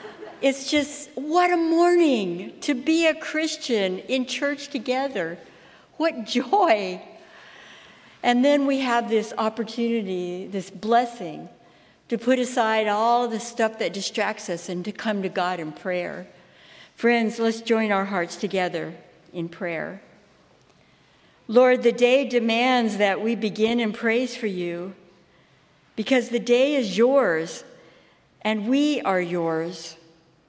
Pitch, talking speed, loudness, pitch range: 225 Hz, 130 wpm, -23 LUFS, 190-255 Hz